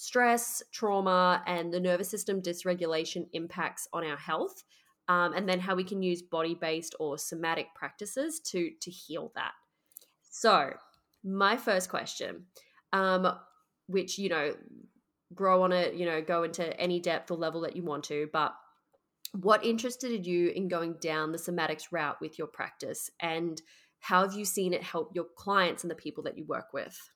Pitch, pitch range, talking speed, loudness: 180 Hz, 165-195 Hz, 170 wpm, -31 LUFS